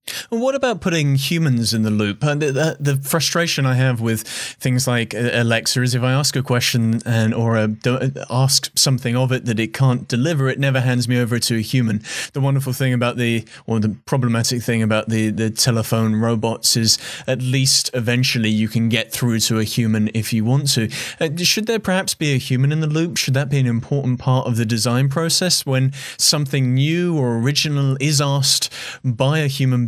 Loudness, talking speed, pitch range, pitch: -18 LUFS, 200 wpm, 115-140 Hz, 130 Hz